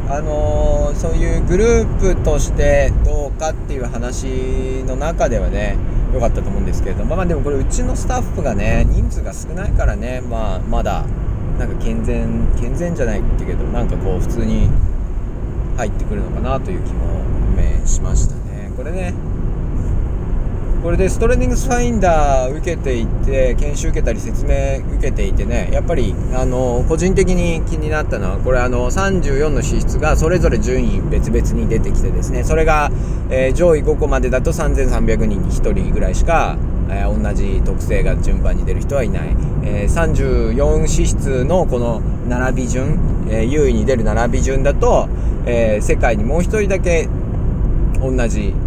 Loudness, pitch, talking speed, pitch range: -18 LUFS, 115 Hz, 320 characters per minute, 95-125 Hz